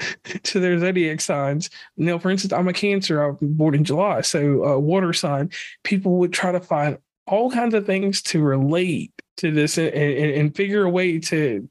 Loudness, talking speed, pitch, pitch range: -21 LUFS, 200 wpm, 175 Hz, 150-190 Hz